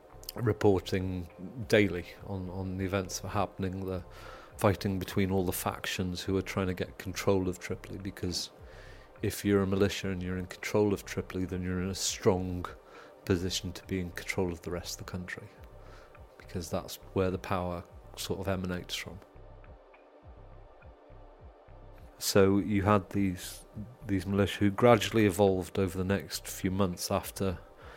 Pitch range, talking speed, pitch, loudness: 90-100 Hz, 160 wpm, 95 Hz, -31 LUFS